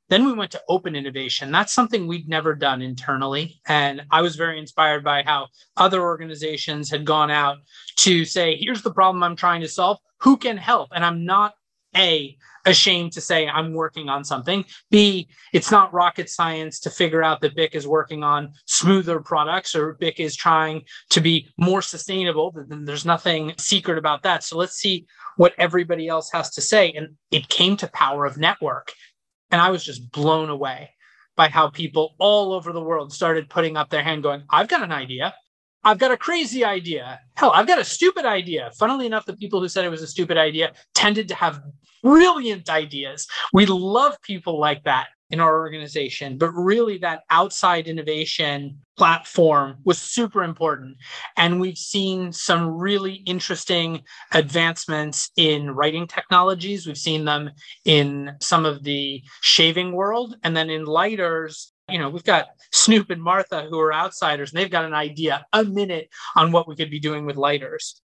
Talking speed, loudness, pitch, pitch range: 180 wpm, -20 LUFS, 165 Hz, 150-185 Hz